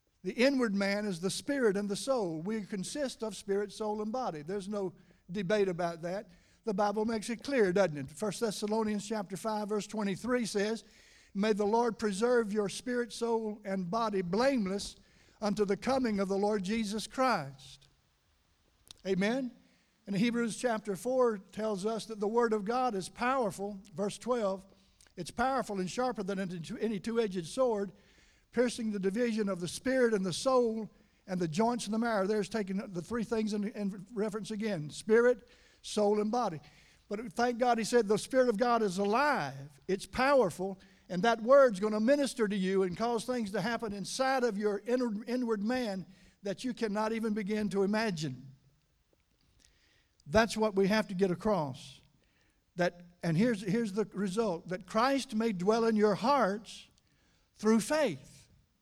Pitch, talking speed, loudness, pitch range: 215 Hz, 165 wpm, -32 LUFS, 195-230 Hz